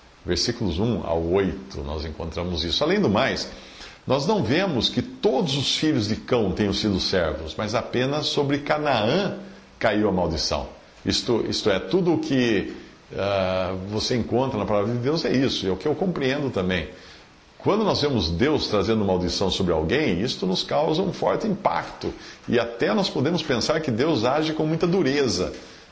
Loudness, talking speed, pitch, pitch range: -23 LUFS, 175 wpm, 105 Hz, 90-130 Hz